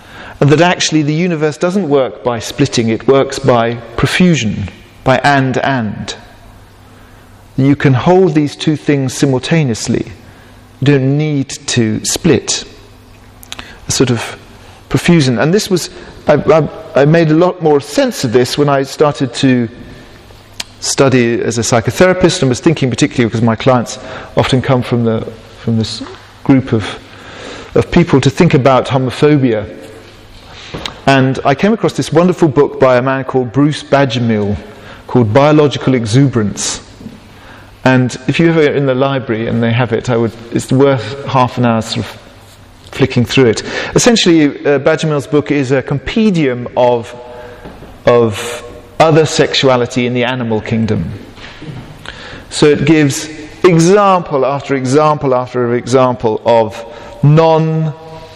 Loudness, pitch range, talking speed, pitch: -12 LUFS, 115-145 Hz, 140 wpm, 130 Hz